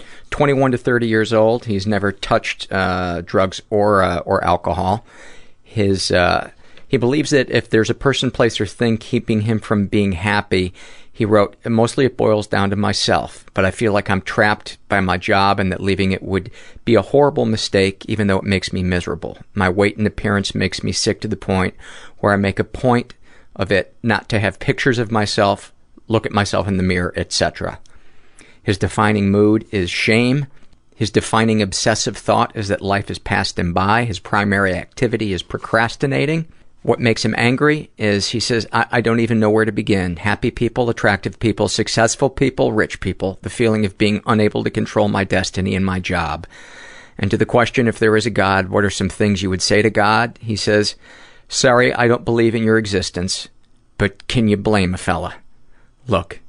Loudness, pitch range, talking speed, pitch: -17 LUFS, 95-115 Hz, 195 wpm, 105 Hz